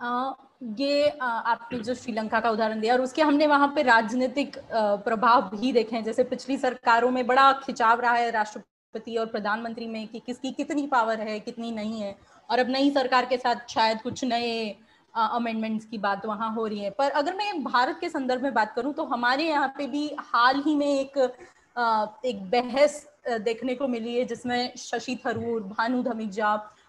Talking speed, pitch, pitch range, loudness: 185 wpm, 245 Hz, 225-270 Hz, -26 LUFS